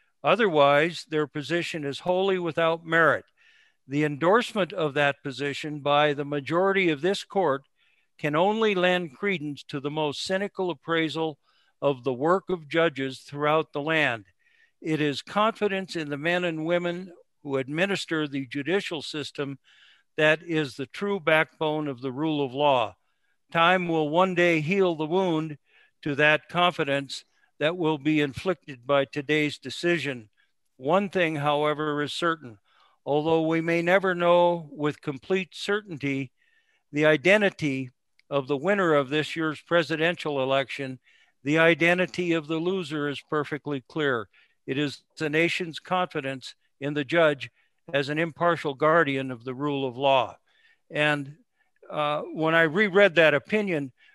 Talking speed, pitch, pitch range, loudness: 145 wpm, 155 Hz, 145-175 Hz, -25 LUFS